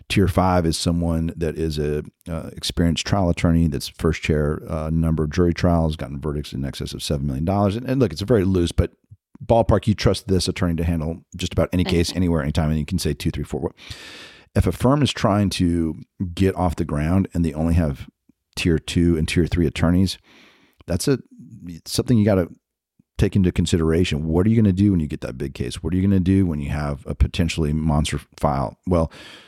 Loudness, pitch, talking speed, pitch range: -21 LUFS, 85 Hz, 225 wpm, 80-95 Hz